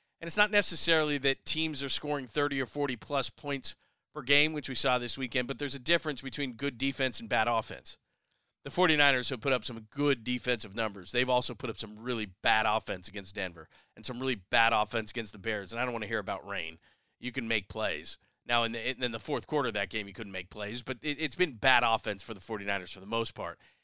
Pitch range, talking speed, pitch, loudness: 110-140 Hz, 240 wpm, 125 Hz, -31 LUFS